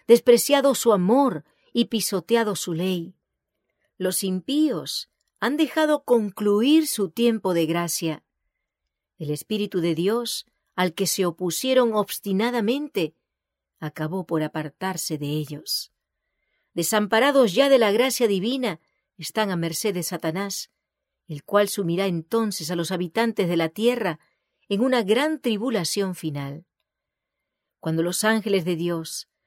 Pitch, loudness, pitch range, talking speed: 200 Hz, -23 LUFS, 170-235 Hz, 125 wpm